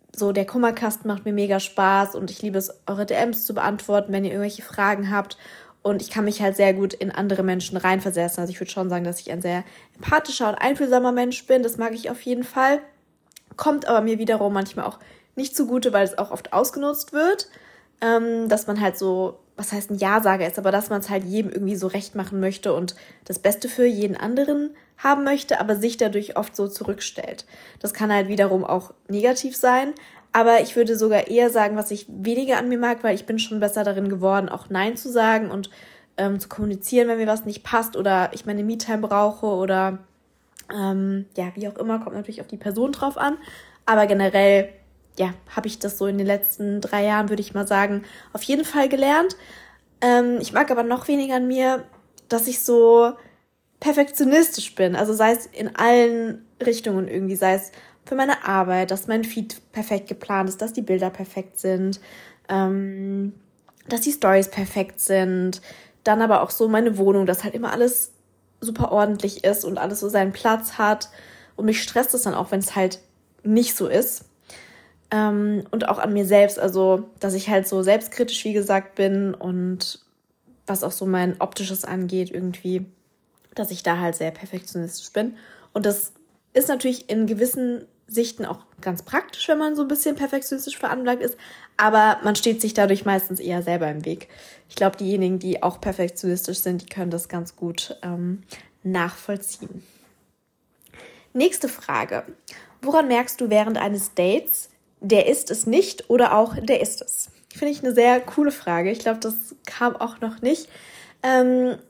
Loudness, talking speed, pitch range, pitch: -22 LUFS, 190 wpm, 195-240 Hz, 210 Hz